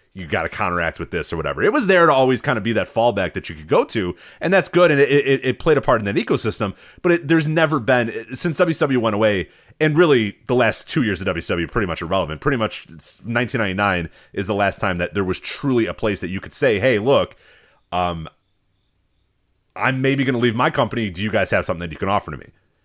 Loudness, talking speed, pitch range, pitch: -19 LUFS, 250 wpm, 95-135 Hz, 110 Hz